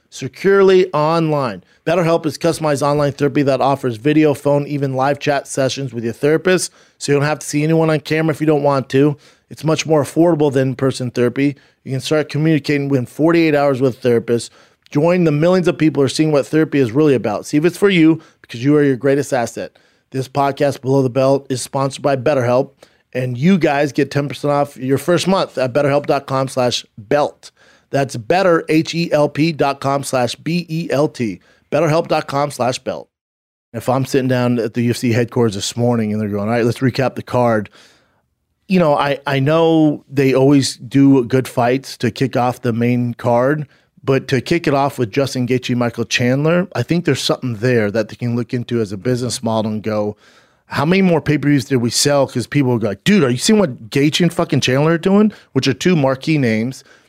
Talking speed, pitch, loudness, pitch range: 205 wpm, 140 Hz, -16 LUFS, 125-155 Hz